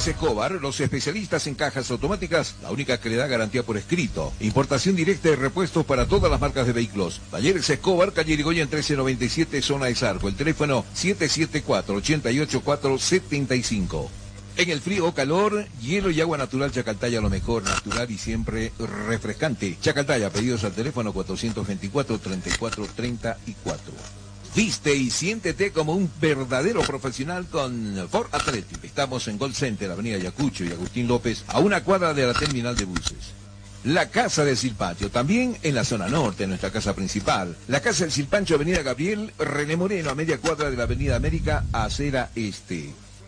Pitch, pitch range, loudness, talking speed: 130 Hz, 105-155 Hz, -24 LUFS, 160 wpm